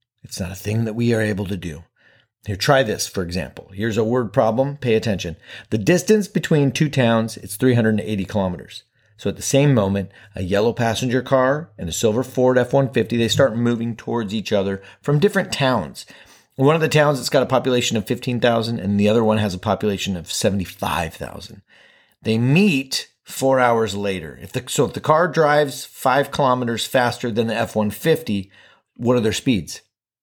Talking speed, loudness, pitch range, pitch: 185 wpm, -20 LUFS, 105-135 Hz, 115 Hz